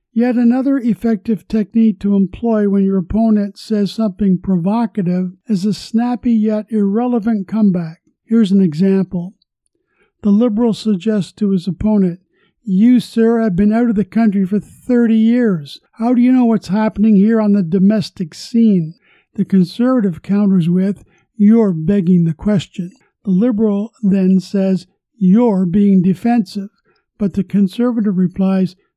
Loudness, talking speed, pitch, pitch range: -15 LUFS, 140 wpm, 205 Hz, 190-225 Hz